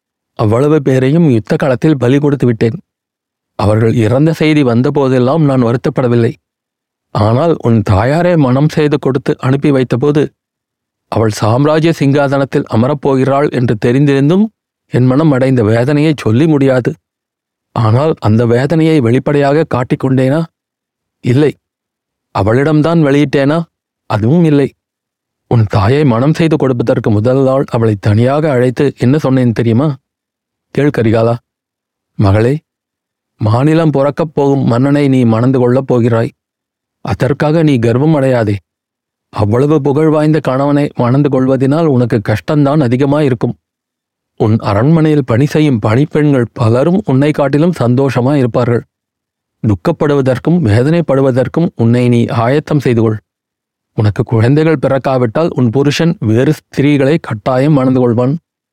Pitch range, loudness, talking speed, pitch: 120-150 Hz, -11 LUFS, 110 wpm, 135 Hz